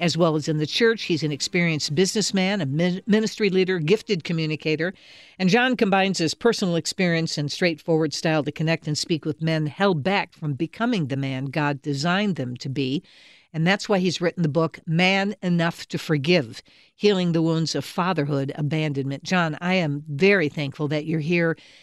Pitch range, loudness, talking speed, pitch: 150-185 Hz, -23 LUFS, 180 wpm, 165 Hz